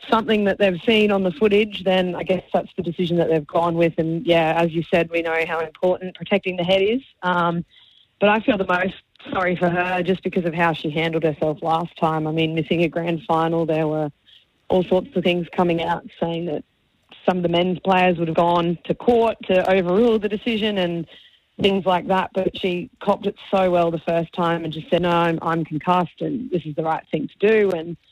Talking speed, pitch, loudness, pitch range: 230 wpm, 175 Hz, -21 LUFS, 165-190 Hz